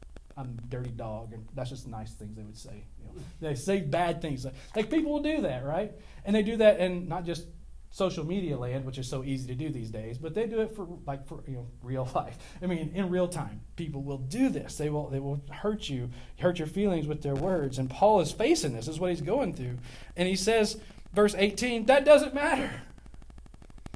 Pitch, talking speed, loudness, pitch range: 160 Hz, 235 wpm, -29 LUFS, 130-195 Hz